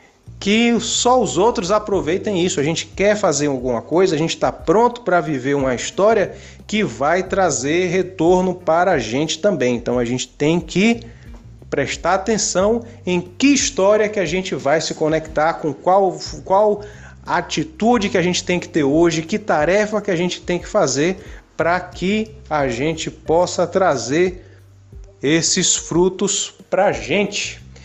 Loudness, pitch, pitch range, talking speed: -18 LUFS, 180 Hz, 150-200 Hz, 160 wpm